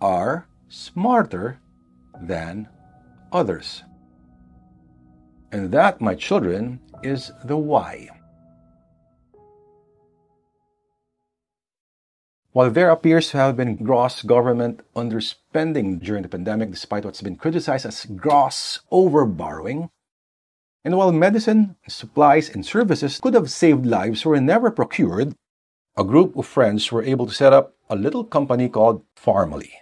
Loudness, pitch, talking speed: -20 LUFS, 115 Hz, 115 wpm